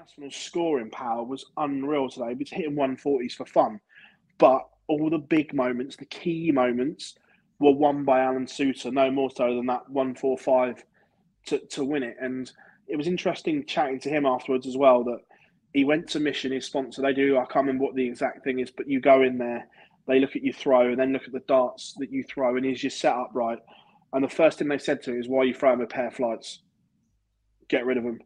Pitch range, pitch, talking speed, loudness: 130-150 Hz, 135 Hz, 225 wpm, -25 LUFS